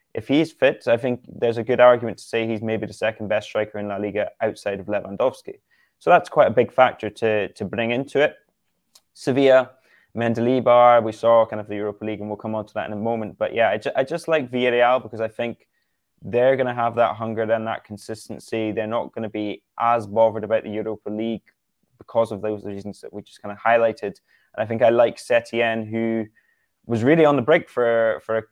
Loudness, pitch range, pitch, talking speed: -21 LUFS, 110-120 Hz, 115 Hz, 225 wpm